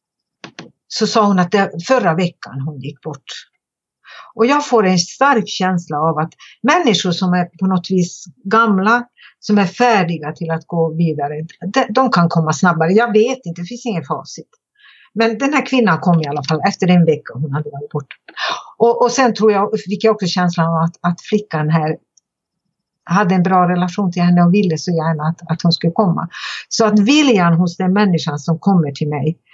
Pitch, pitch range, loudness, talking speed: 180 Hz, 165-215 Hz, -15 LUFS, 200 wpm